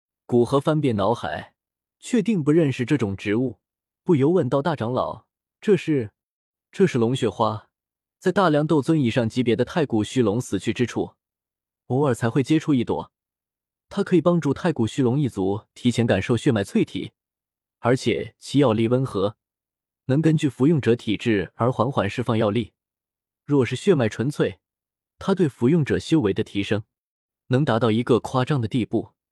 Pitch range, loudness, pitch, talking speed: 110-150 Hz, -22 LUFS, 125 Hz, 250 characters per minute